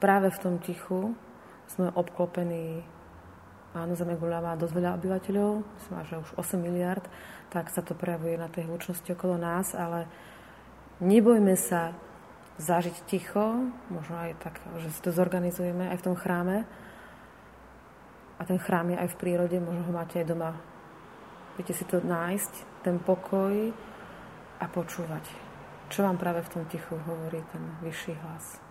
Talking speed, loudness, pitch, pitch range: 150 wpm, -30 LUFS, 175 Hz, 170-185 Hz